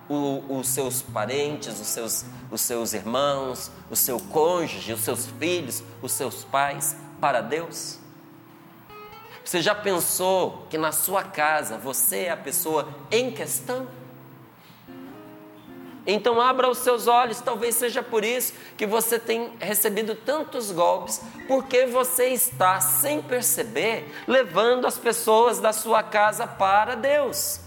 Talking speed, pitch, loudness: 130 wpm, 190 Hz, -23 LUFS